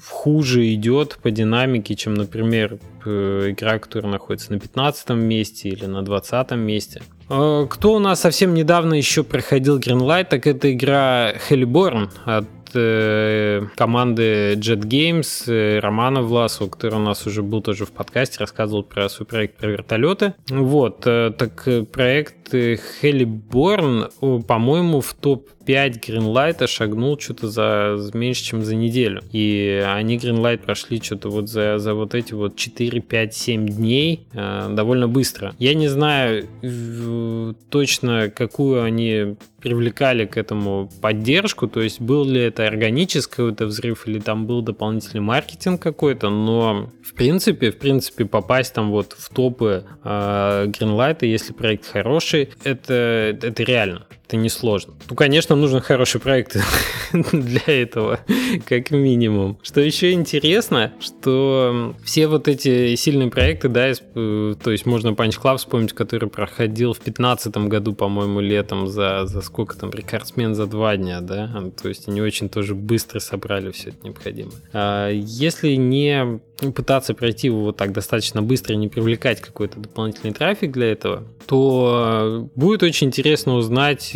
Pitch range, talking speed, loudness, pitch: 105-135 Hz, 145 wpm, -19 LUFS, 115 Hz